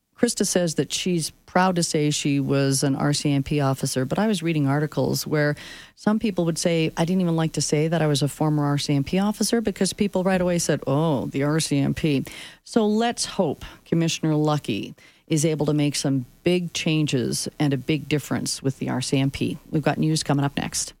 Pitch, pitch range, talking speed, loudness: 155 Hz, 145-175 Hz, 195 wpm, -23 LUFS